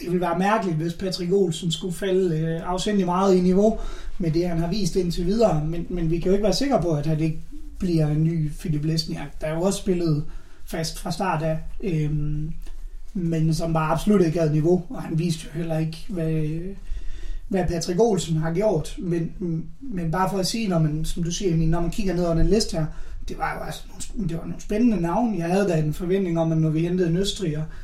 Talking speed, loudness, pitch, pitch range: 230 wpm, -24 LUFS, 170 Hz, 160-190 Hz